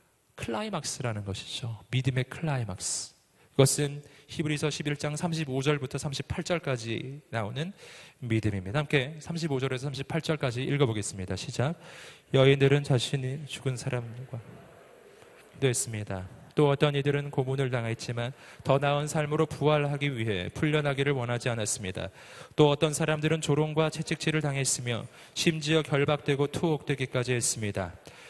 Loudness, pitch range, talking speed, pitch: -29 LUFS, 125-150 Hz, 310 characters per minute, 140 Hz